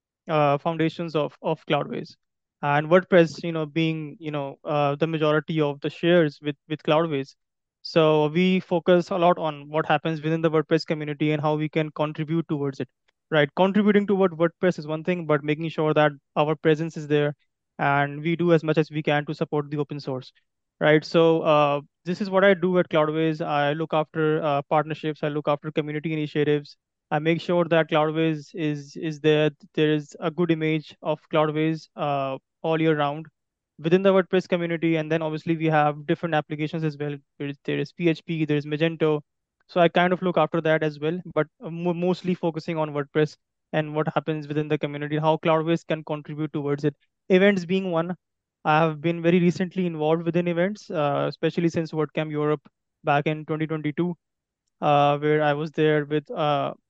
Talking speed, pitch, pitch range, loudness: 190 wpm, 155 Hz, 150-170 Hz, -24 LUFS